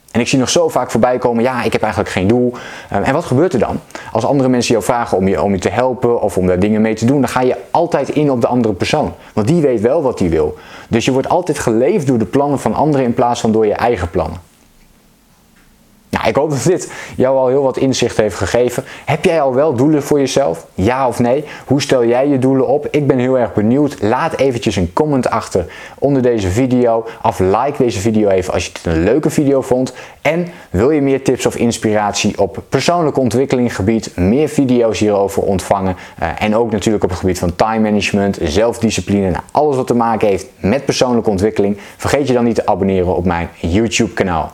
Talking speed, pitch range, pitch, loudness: 220 wpm, 105-130 Hz, 115 Hz, -14 LUFS